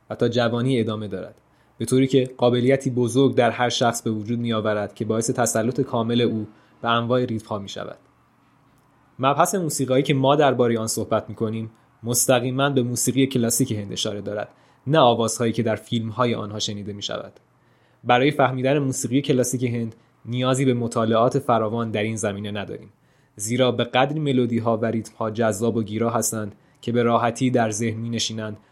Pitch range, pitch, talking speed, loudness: 110-130 Hz, 120 Hz, 170 wpm, -22 LUFS